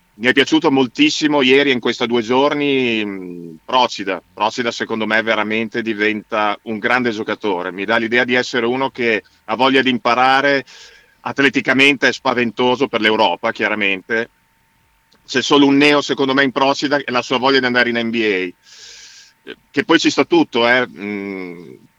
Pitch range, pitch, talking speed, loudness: 110-135 Hz, 120 Hz, 160 wpm, -16 LUFS